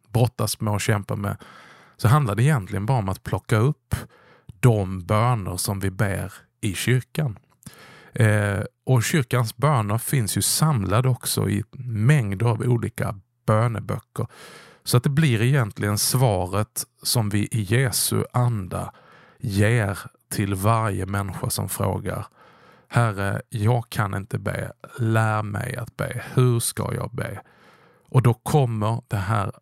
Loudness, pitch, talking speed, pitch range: -23 LUFS, 115 Hz, 140 wpm, 105-125 Hz